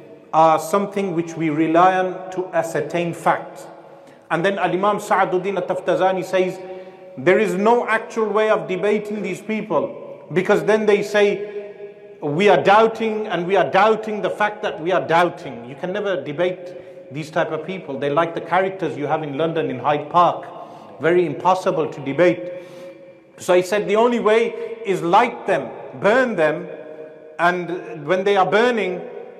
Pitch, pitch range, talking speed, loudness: 180 Hz, 165-205 Hz, 165 wpm, -19 LUFS